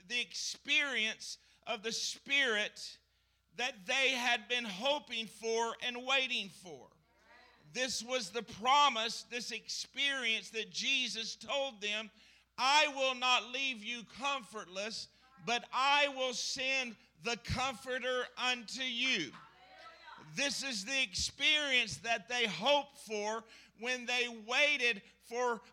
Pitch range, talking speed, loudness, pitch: 225-265 Hz, 115 wpm, -34 LUFS, 245 Hz